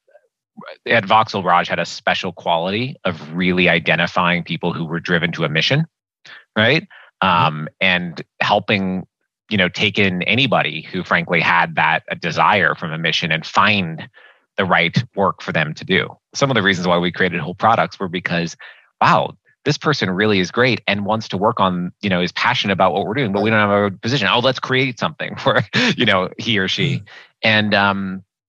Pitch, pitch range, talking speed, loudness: 100 Hz, 90-110 Hz, 195 wpm, -17 LUFS